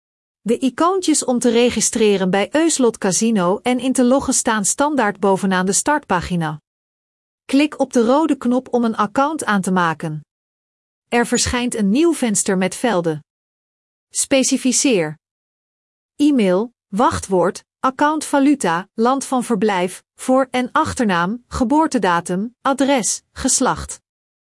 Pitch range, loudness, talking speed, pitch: 195-270 Hz, -17 LUFS, 120 wpm, 240 Hz